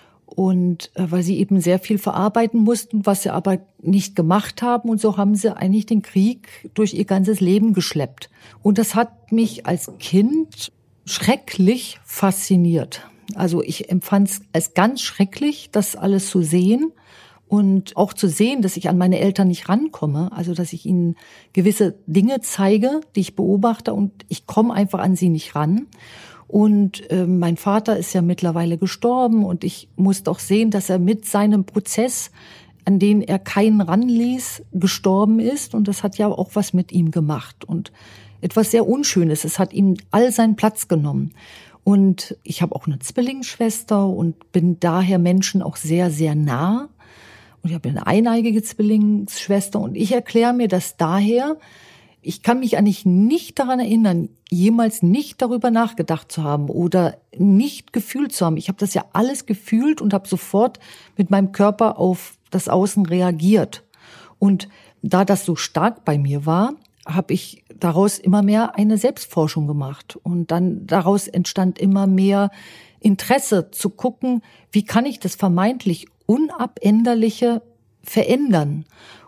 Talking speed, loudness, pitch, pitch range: 160 wpm, -19 LUFS, 195 Hz, 180-220 Hz